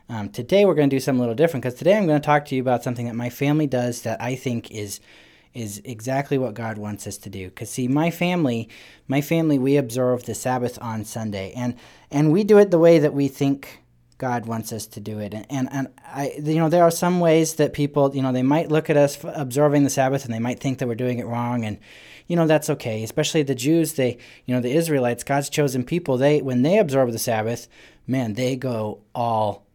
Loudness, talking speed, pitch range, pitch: -22 LUFS, 245 wpm, 115-150 Hz, 130 Hz